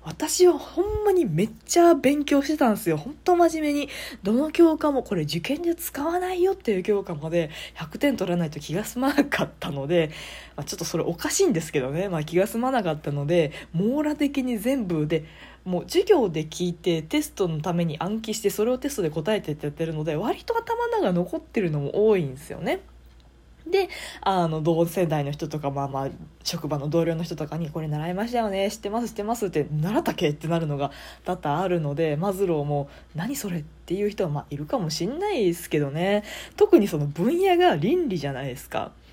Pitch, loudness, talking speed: 190 Hz, -25 LUFS, 405 characters per minute